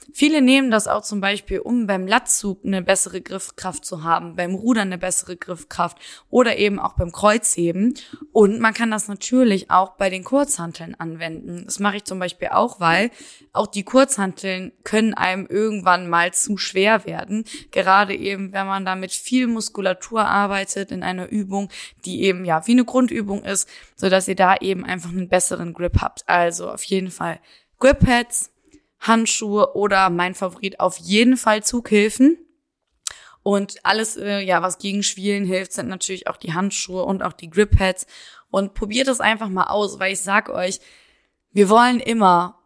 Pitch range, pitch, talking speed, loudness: 185-220 Hz, 200 Hz, 175 wpm, -20 LUFS